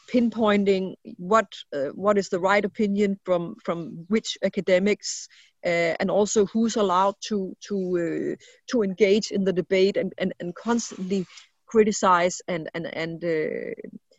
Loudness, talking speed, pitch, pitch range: -24 LUFS, 145 wpm, 195 Hz, 180-215 Hz